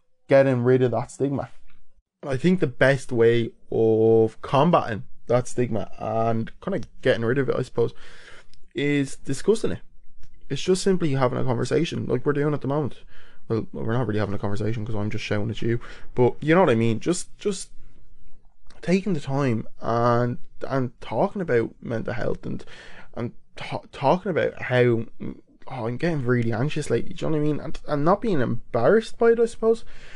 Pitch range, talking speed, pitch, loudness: 115-150 Hz, 190 wpm, 130 Hz, -24 LUFS